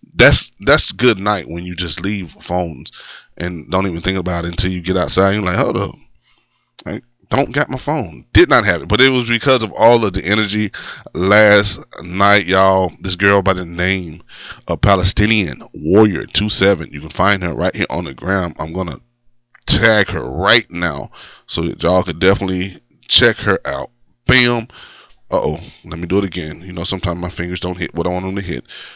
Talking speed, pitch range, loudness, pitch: 205 wpm, 90-105 Hz, -15 LUFS, 95 Hz